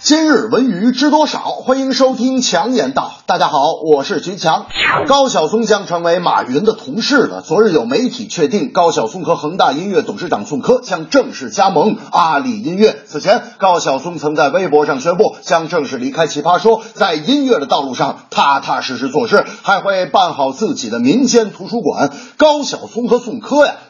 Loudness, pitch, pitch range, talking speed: -14 LUFS, 230 Hz, 180-255 Hz, 285 characters per minute